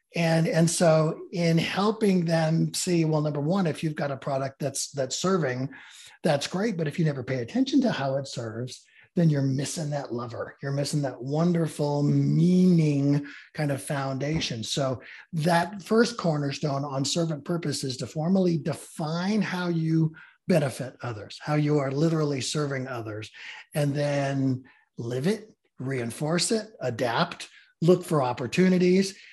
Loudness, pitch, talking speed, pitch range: -26 LUFS, 155 Hz, 150 wpm, 135-170 Hz